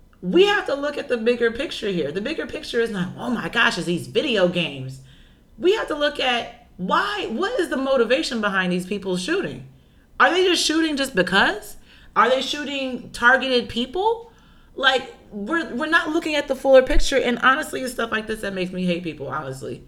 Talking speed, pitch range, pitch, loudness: 200 wpm, 185-290 Hz, 245 Hz, -21 LUFS